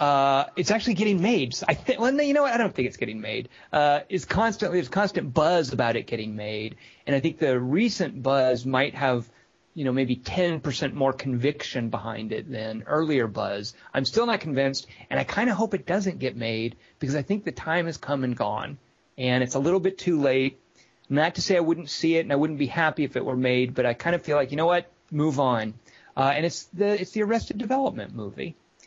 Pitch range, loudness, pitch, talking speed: 130-180 Hz, -25 LUFS, 145 Hz, 235 wpm